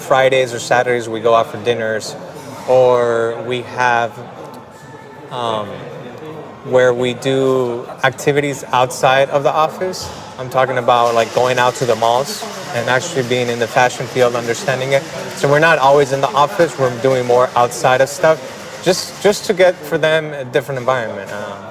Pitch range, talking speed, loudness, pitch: 120-145 Hz, 170 wpm, -15 LUFS, 130 Hz